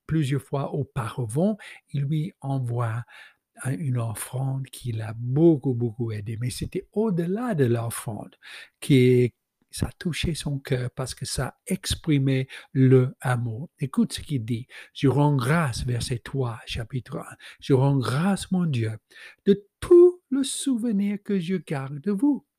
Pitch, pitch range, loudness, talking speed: 140 Hz, 125-180 Hz, -25 LUFS, 145 wpm